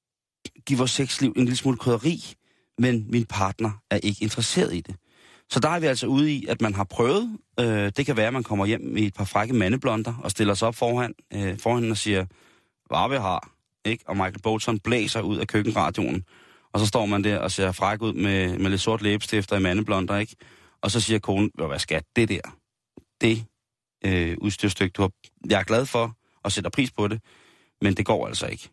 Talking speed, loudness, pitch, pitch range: 205 wpm, -25 LUFS, 110 Hz, 100-120 Hz